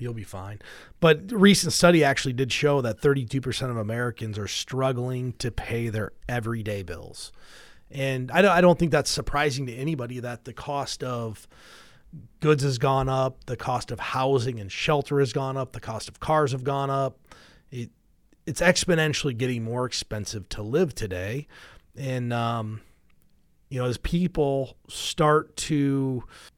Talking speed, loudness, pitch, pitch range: 160 wpm, -25 LUFS, 130 Hz, 115-145 Hz